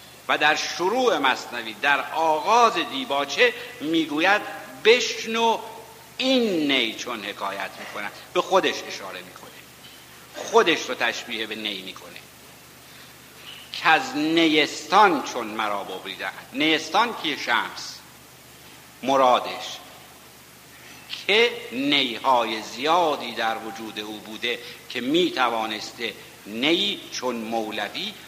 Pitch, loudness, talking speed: 150 Hz, -23 LUFS, 100 wpm